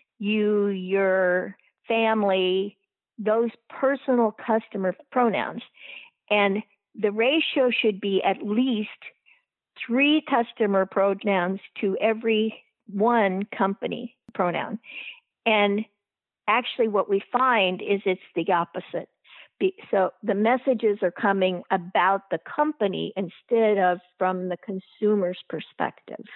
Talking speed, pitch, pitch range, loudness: 100 wpm, 210 Hz, 195-235 Hz, -24 LUFS